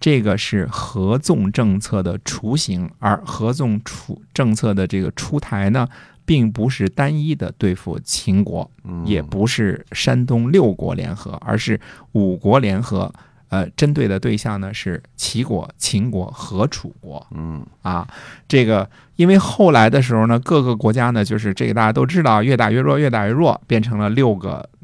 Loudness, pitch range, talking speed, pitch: -18 LUFS, 100-130 Hz, 245 characters per minute, 110 Hz